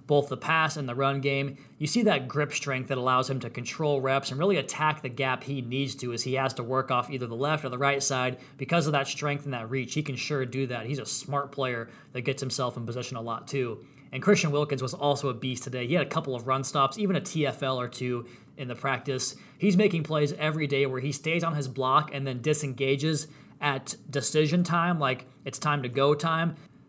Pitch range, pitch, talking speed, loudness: 130-150 Hz, 140 Hz, 245 wpm, -28 LUFS